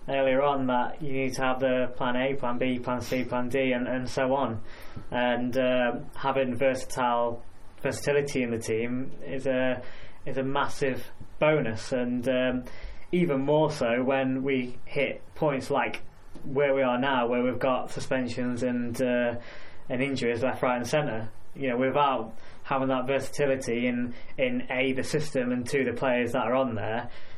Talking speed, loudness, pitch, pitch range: 175 wpm, -28 LUFS, 130 Hz, 120-135 Hz